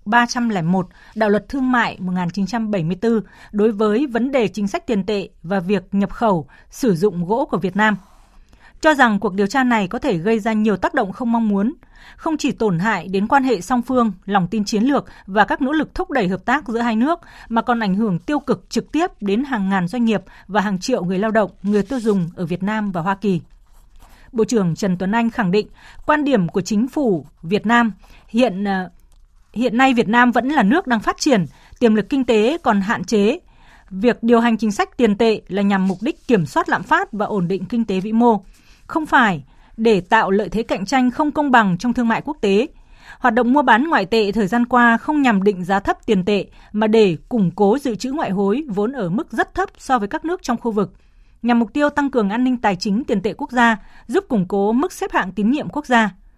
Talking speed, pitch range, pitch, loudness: 235 wpm, 200-250 Hz, 225 Hz, -18 LUFS